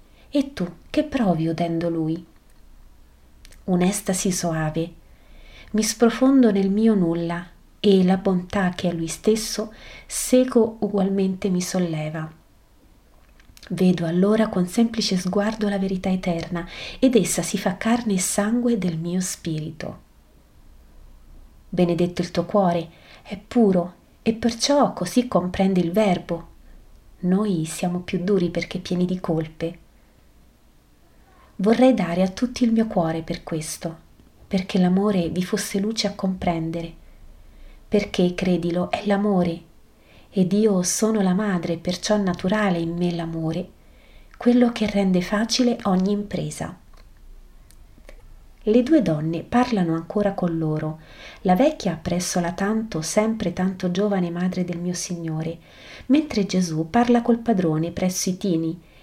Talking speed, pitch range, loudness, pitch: 125 wpm, 170-210 Hz, -22 LUFS, 185 Hz